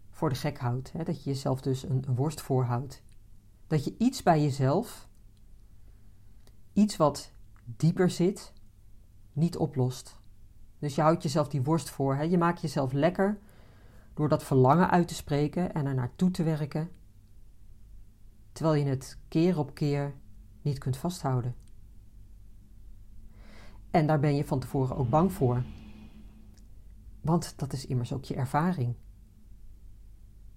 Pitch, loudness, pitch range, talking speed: 130 Hz, -29 LUFS, 105-155 Hz, 135 wpm